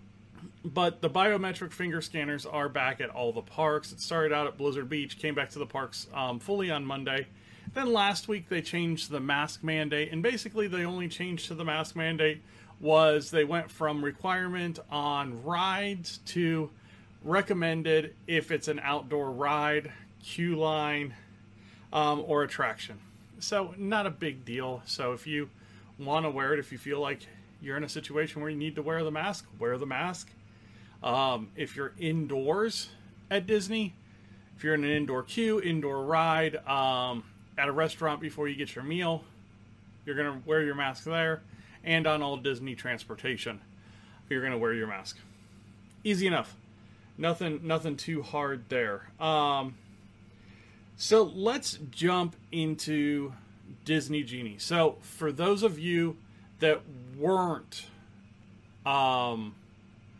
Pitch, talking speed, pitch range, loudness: 145 Hz, 155 wpm, 110-160 Hz, -31 LUFS